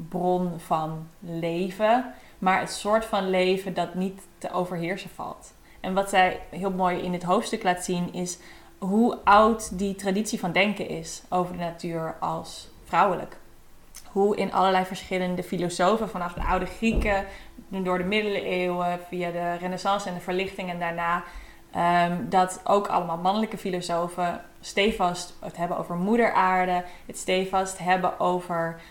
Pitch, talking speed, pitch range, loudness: 185 Hz, 150 wpm, 175-195 Hz, -26 LUFS